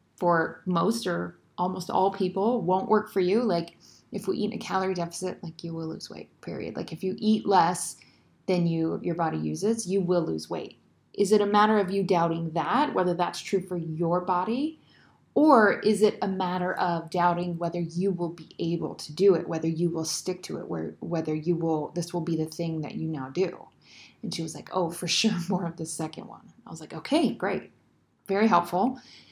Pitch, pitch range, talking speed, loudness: 175 Hz, 165-195 Hz, 215 wpm, -27 LUFS